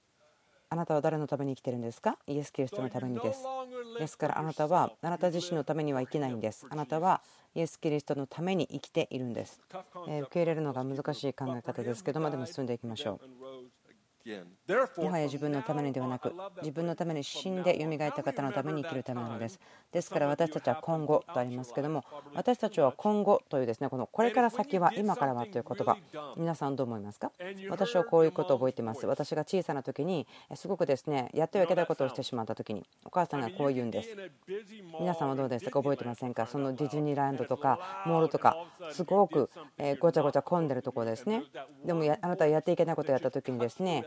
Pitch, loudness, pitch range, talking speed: 150 Hz, -32 LUFS, 130-170 Hz, 470 characters per minute